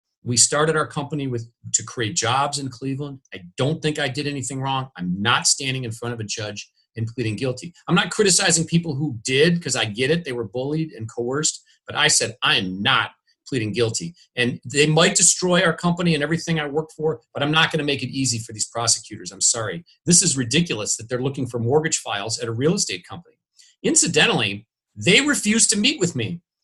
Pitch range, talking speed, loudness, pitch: 120-160 Hz, 215 wpm, -20 LUFS, 140 Hz